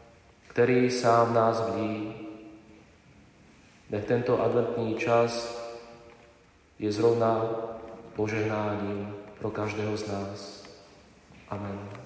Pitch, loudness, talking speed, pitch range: 110 Hz, -28 LUFS, 80 wpm, 105-115 Hz